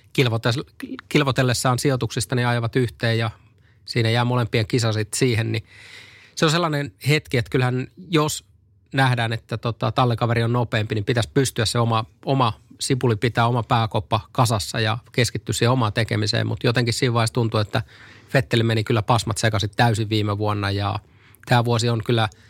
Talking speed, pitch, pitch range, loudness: 160 wpm, 115 Hz, 110-125 Hz, -22 LUFS